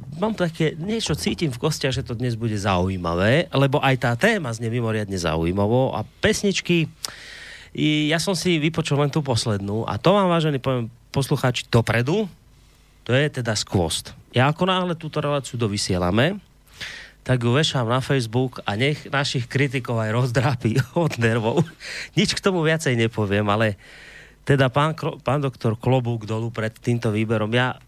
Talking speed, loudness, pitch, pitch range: 155 wpm, -22 LUFS, 130 Hz, 115-150 Hz